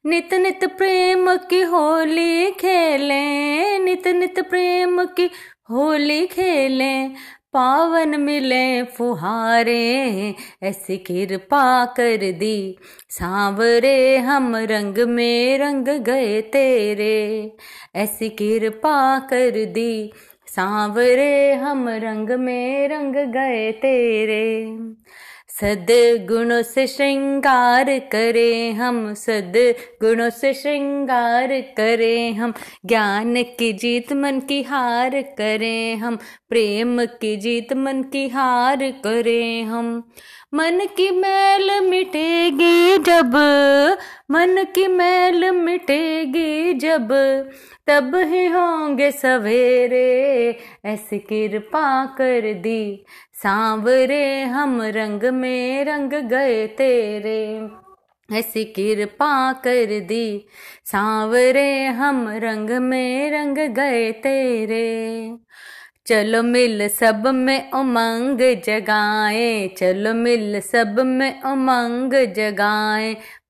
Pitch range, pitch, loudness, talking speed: 225-280 Hz, 250 Hz, -18 LUFS, 90 wpm